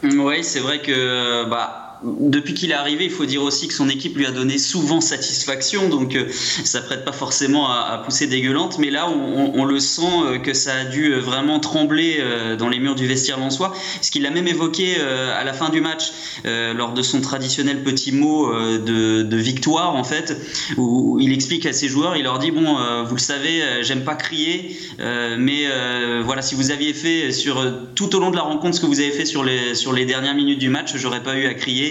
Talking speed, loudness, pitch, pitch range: 220 wpm, -19 LUFS, 140 Hz, 130-155 Hz